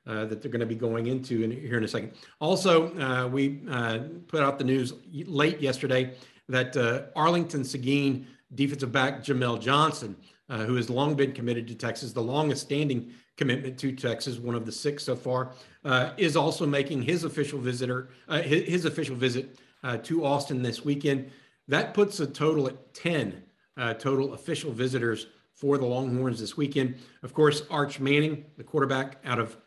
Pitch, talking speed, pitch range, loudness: 135 Hz, 180 wpm, 125-145 Hz, -28 LUFS